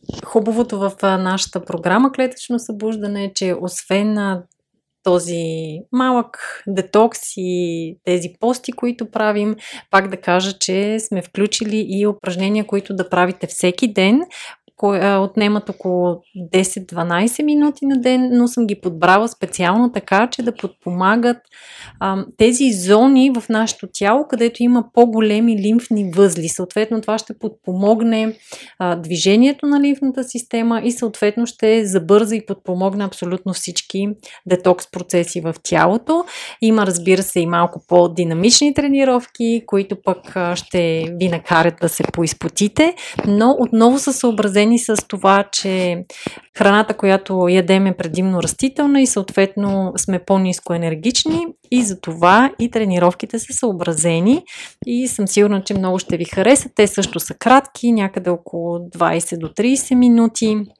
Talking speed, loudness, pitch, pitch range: 135 wpm, -17 LUFS, 205 Hz, 185-235 Hz